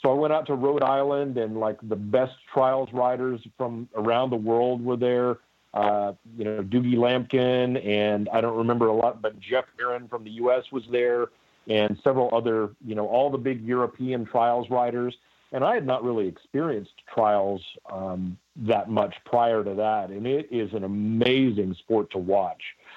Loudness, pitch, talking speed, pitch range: -25 LUFS, 120 Hz, 185 wpm, 110-125 Hz